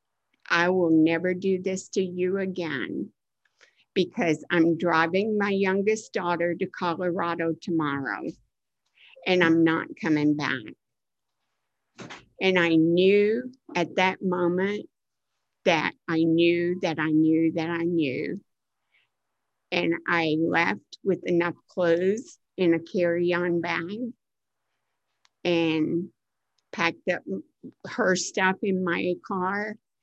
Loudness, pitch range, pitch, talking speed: -25 LUFS, 165-190 Hz, 175 Hz, 110 wpm